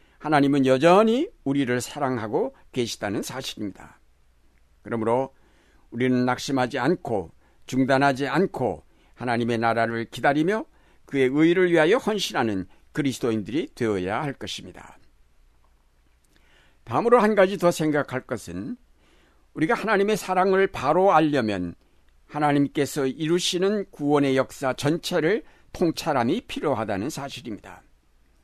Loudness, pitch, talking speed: -23 LUFS, 130 Hz, 290 characters per minute